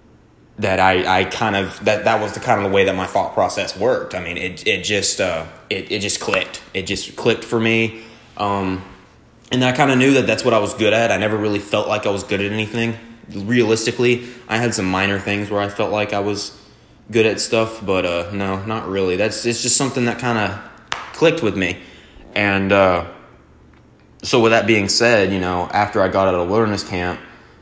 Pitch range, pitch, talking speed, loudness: 95-115 Hz, 105 Hz, 220 wpm, -18 LUFS